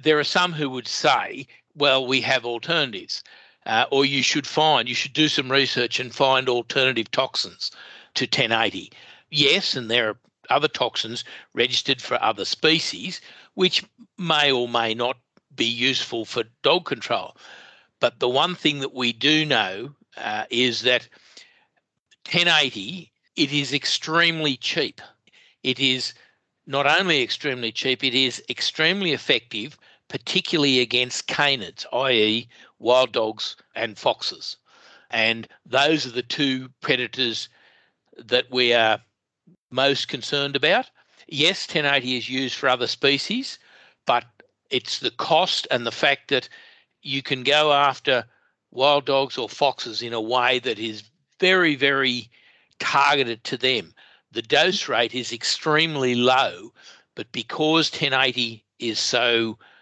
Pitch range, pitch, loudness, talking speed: 120-150 Hz, 130 Hz, -21 LUFS, 135 wpm